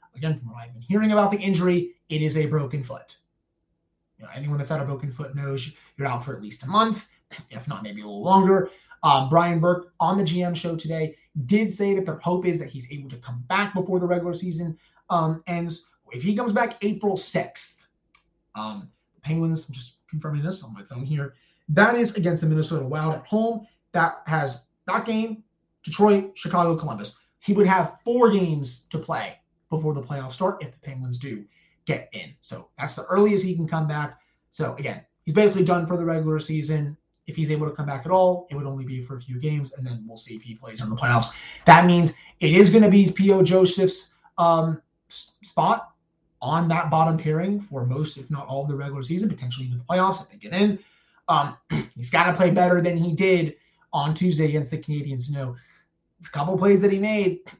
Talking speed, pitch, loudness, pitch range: 220 wpm, 165 Hz, -23 LUFS, 145-185 Hz